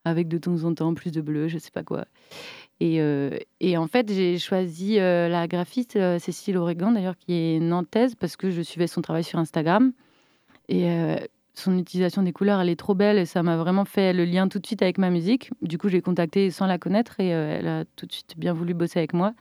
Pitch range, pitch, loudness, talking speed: 170-195 Hz, 180 Hz, -24 LUFS, 240 wpm